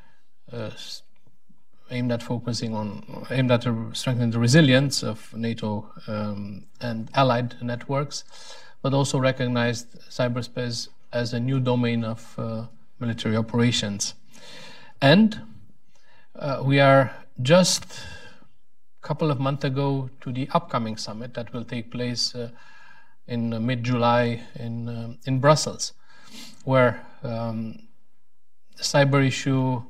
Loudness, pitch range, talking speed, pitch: -24 LUFS, 115-140 Hz, 120 wpm, 125 Hz